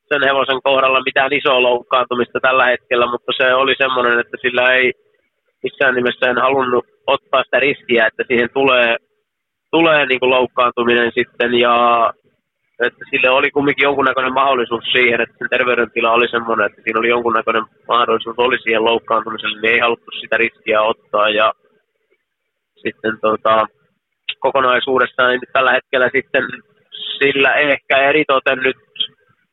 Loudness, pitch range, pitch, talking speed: -15 LUFS, 120-135 Hz, 125 Hz, 135 wpm